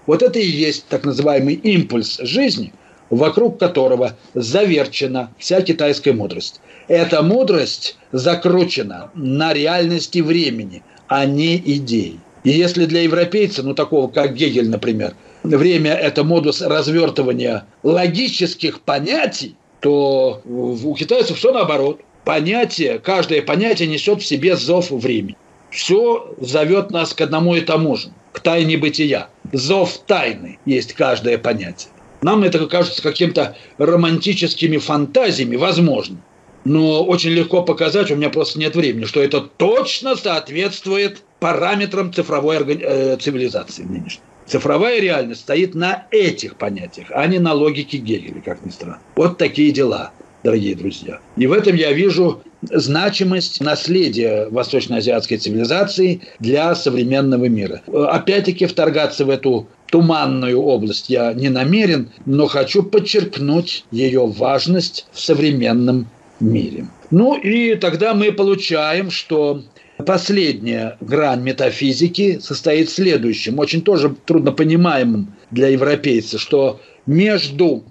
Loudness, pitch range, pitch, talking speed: -16 LUFS, 140-185 Hz, 160 Hz, 120 wpm